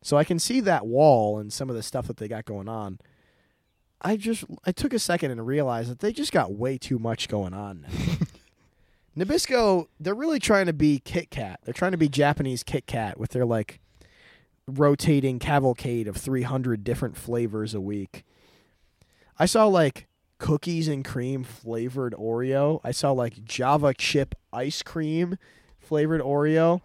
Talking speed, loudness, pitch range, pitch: 170 wpm, -25 LUFS, 115-160 Hz, 135 Hz